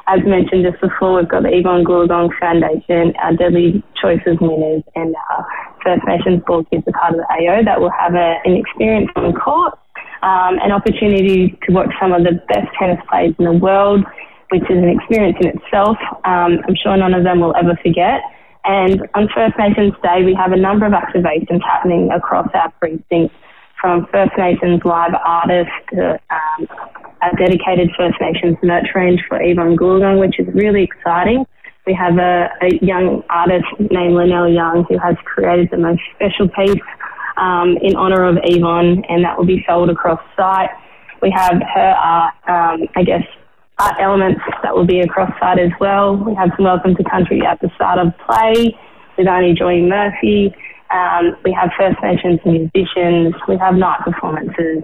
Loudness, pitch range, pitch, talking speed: -14 LUFS, 175-190 Hz, 180 Hz, 185 wpm